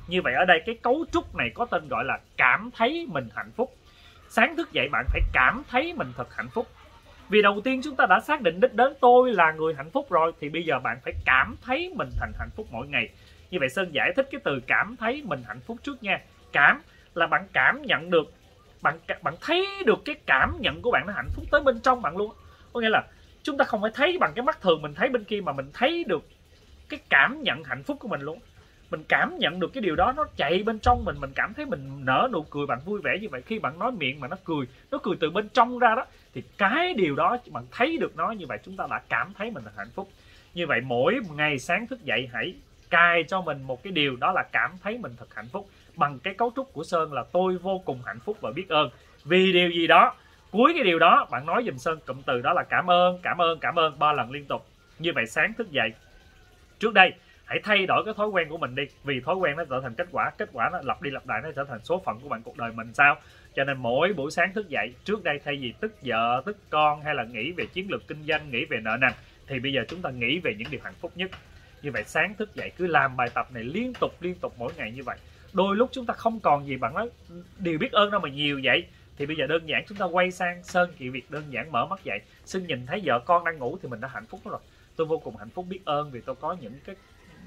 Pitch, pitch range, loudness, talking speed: 180 Hz, 150-235 Hz, -25 LUFS, 275 wpm